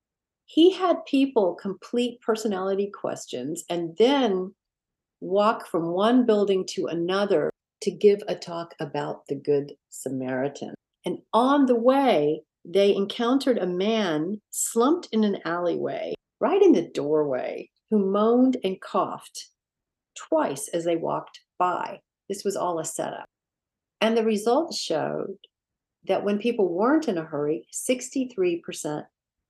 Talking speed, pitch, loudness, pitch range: 130 wpm, 200 Hz, -25 LUFS, 170-240 Hz